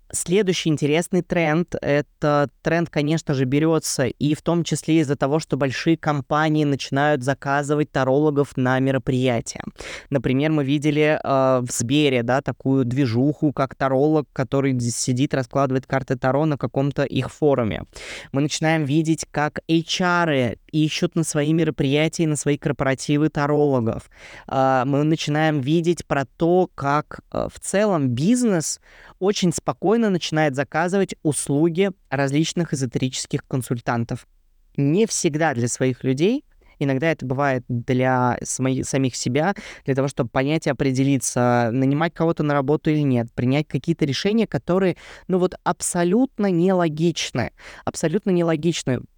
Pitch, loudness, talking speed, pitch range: 145 Hz, -21 LUFS, 130 wpm, 135-165 Hz